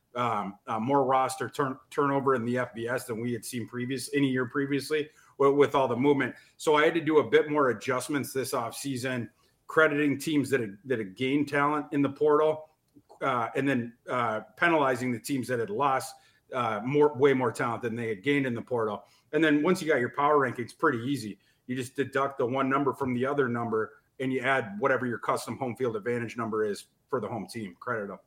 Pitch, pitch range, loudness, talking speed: 135 Hz, 120-145 Hz, -28 LUFS, 220 wpm